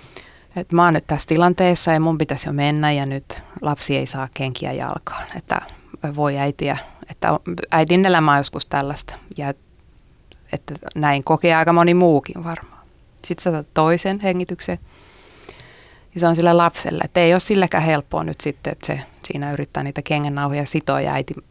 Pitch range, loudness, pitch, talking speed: 140-170 Hz, -19 LUFS, 155 Hz, 160 wpm